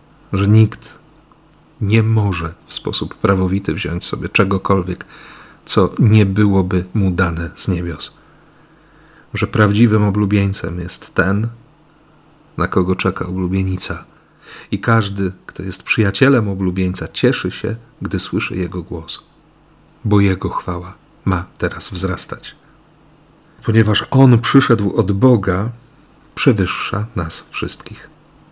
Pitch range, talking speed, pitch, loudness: 95-130 Hz, 110 wpm, 105 Hz, -17 LUFS